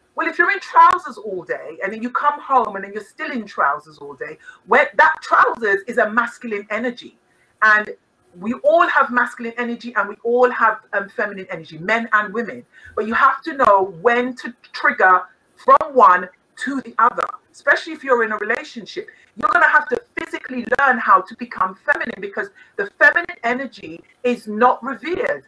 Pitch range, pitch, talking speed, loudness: 210-295 Hz, 245 Hz, 190 wpm, -18 LUFS